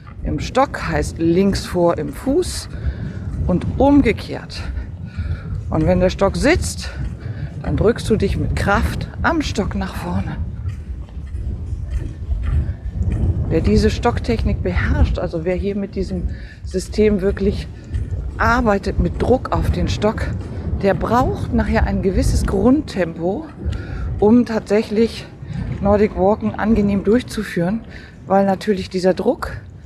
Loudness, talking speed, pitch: -19 LUFS, 115 wpm, 125 Hz